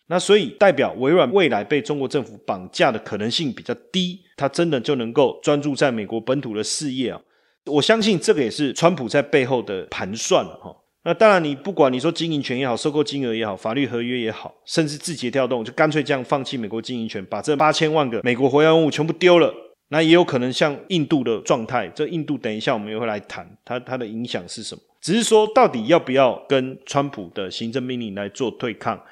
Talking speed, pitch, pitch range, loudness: 350 characters per minute, 145 Hz, 125-165 Hz, -20 LUFS